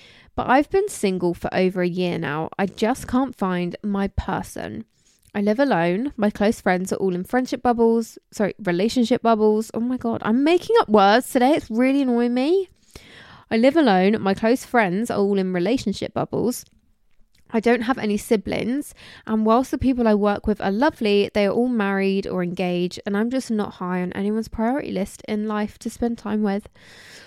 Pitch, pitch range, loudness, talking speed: 215 Hz, 200-245 Hz, -21 LUFS, 190 wpm